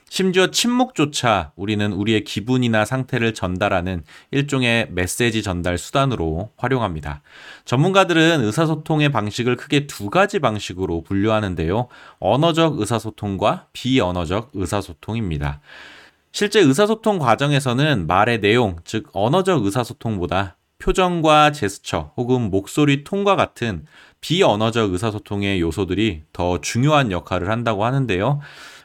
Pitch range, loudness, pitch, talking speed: 95-140 Hz, -19 LUFS, 115 Hz, 320 characters per minute